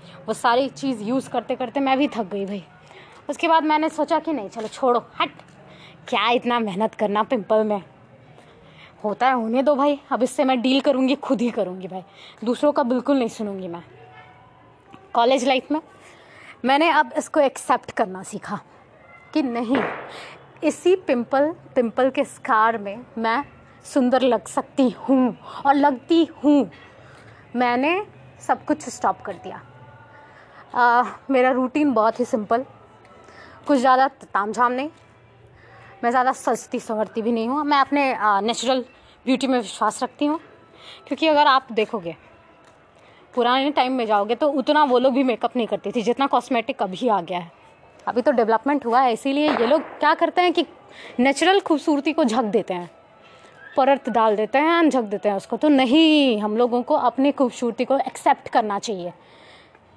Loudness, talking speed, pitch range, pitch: -21 LUFS, 160 wpm, 220-280 Hz, 255 Hz